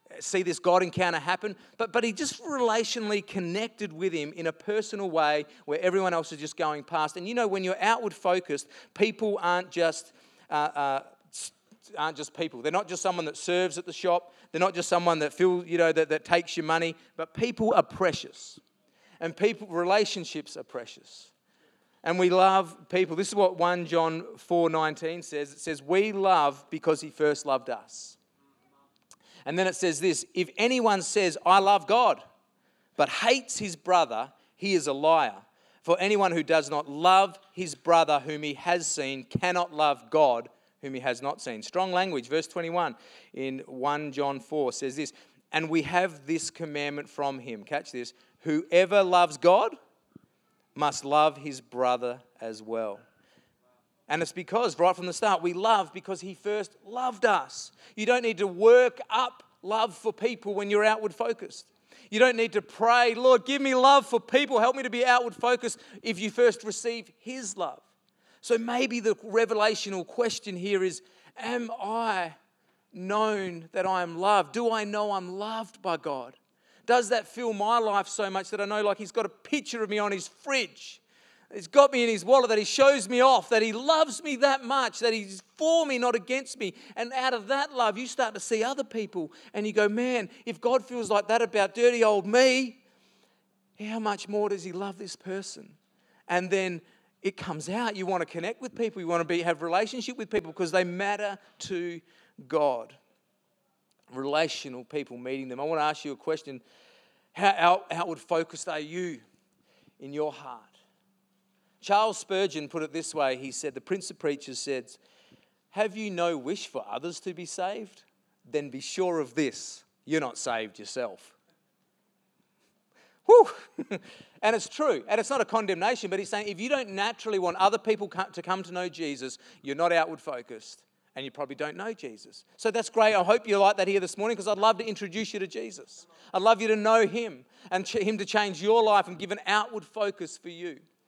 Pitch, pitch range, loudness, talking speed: 190 Hz, 165-220 Hz, -27 LUFS, 195 wpm